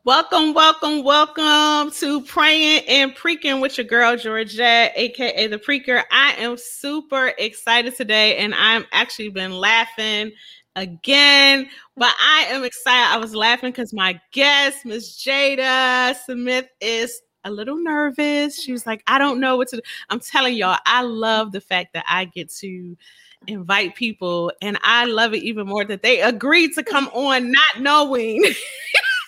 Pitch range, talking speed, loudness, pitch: 225-285 Hz, 160 wpm, -17 LUFS, 250 Hz